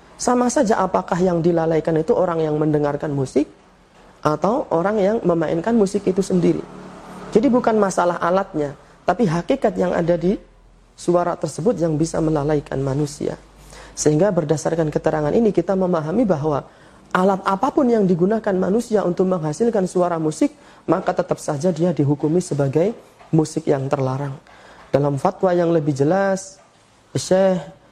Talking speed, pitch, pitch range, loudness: 135 wpm, 175 Hz, 155-195 Hz, -20 LUFS